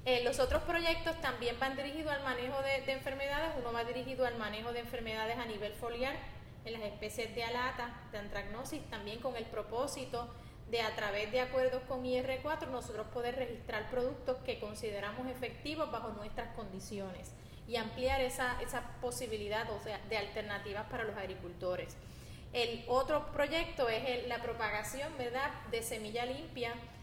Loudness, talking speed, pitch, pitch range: -38 LUFS, 160 wpm, 245 Hz, 225-265 Hz